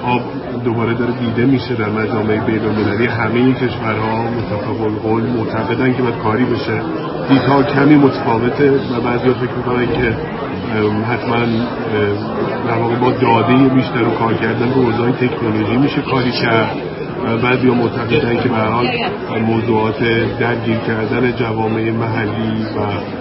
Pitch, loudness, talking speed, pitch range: 115 Hz, -16 LUFS, 145 wpm, 110-125 Hz